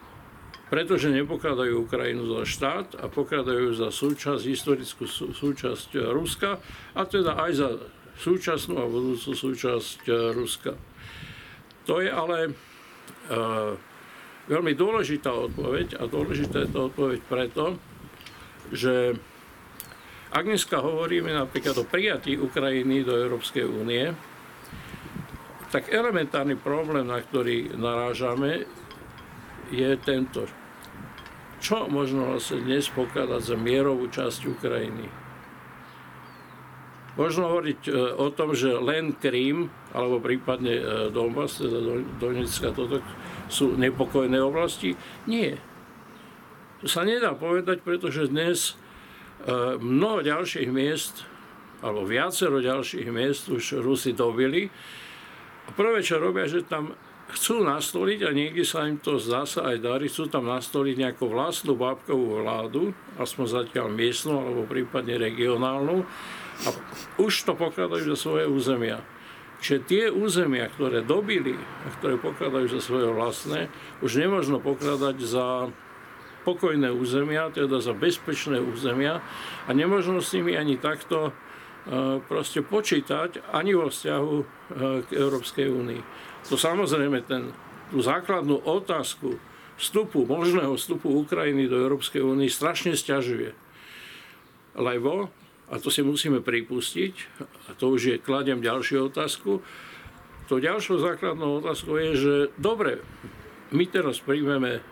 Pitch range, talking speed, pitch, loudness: 125-150 Hz, 115 wpm, 135 Hz, -26 LUFS